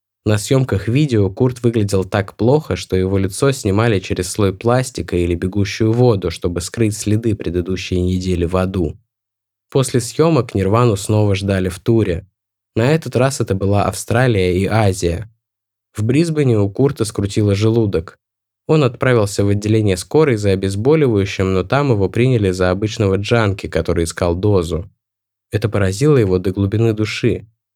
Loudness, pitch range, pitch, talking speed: -17 LUFS, 95-115 Hz, 105 Hz, 145 wpm